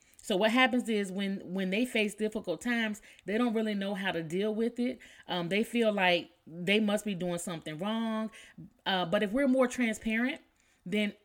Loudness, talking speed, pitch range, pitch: -31 LUFS, 190 wpm, 190-225 Hz, 210 Hz